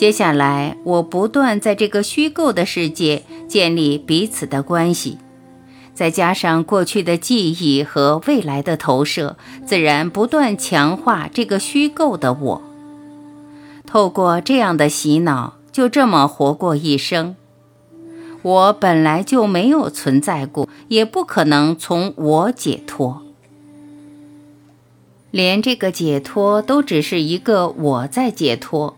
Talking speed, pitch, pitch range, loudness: 190 characters per minute, 170 Hz, 145-215 Hz, -16 LUFS